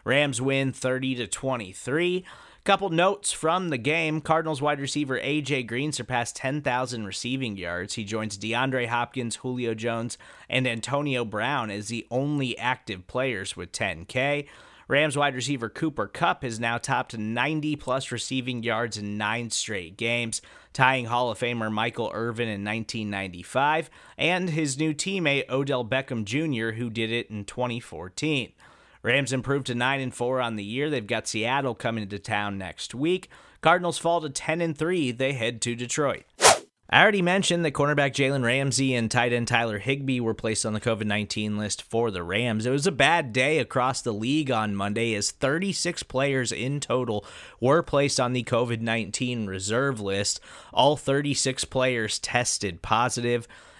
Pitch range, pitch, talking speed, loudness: 115-140 Hz, 125 Hz, 165 wpm, -26 LUFS